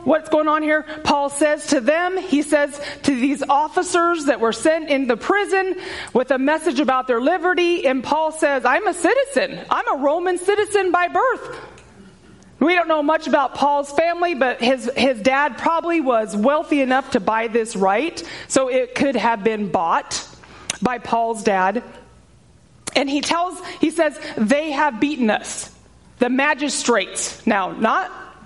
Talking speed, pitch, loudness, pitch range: 165 wpm, 290 Hz, -19 LUFS, 260-330 Hz